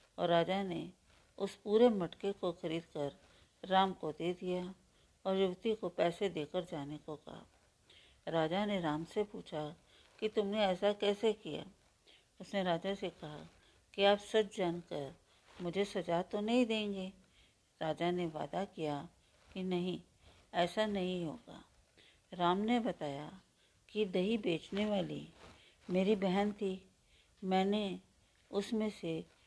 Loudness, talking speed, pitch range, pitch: -37 LUFS, 135 wpm, 165-200 Hz, 185 Hz